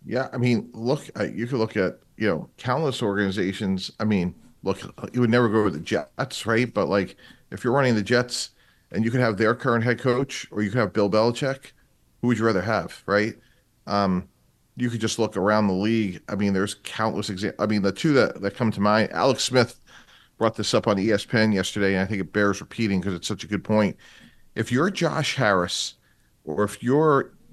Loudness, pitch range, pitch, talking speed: -24 LUFS, 100-120 Hz, 110 Hz, 215 wpm